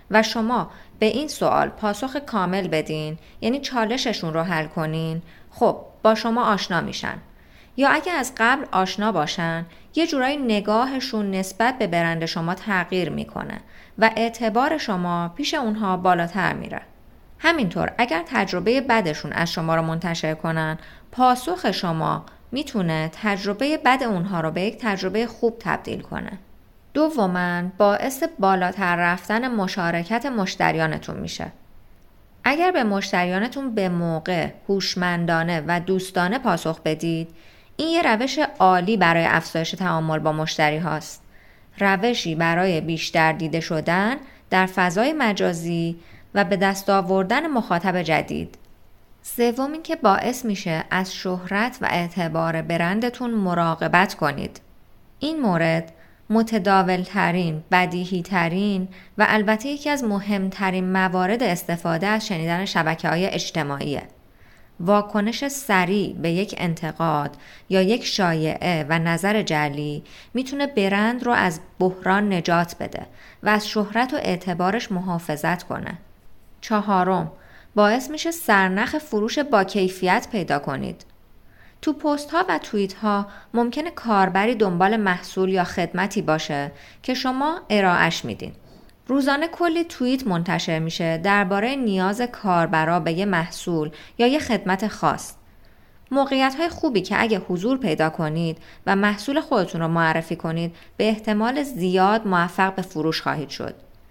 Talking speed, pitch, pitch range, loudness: 125 wpm, 190 Hz, 170-230 Hz, -22 LUFS